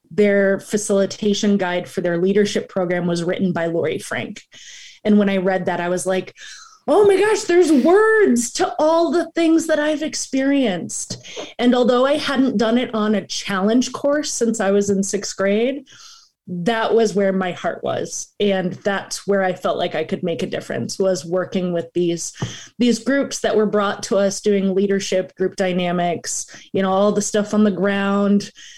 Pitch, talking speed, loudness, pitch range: 205 Hz, 185 wpm, -19 LUFS, 190-245 Hz